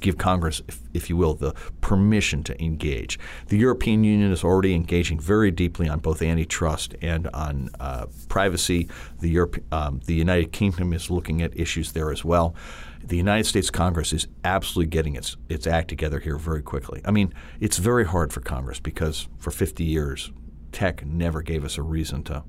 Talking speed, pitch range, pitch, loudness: 185 wpm, 75-90 Hz, 80 Hz, -24 LUFS